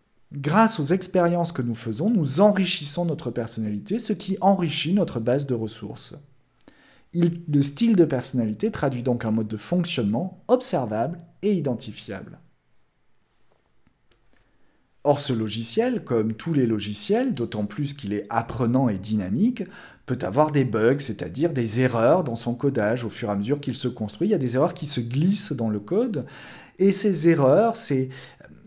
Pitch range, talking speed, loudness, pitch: 115-180 Hz, 165 wpm, -24 LUFS, 140 Hz